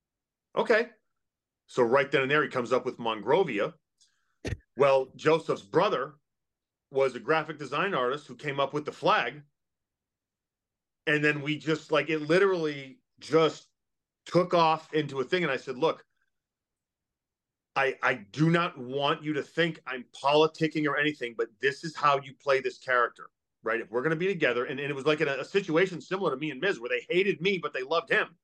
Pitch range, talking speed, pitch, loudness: 135-165 Hz, 190 wpm, 150 Hz, -28 LUFS